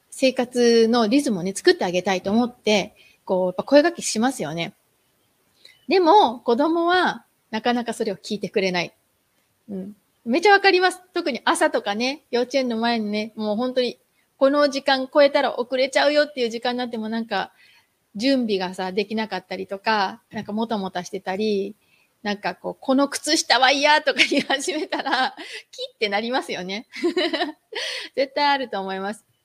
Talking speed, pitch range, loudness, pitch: 345 characters per minute, 205-285 Hz, -21 LUFS, 240 Hz